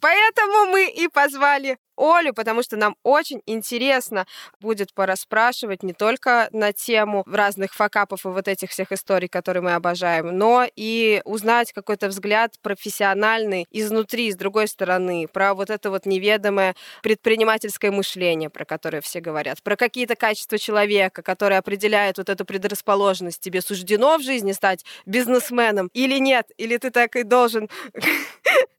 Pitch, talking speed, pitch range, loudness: 210 Hz, 145 wpm, 195-235 Hz, -20 LUFS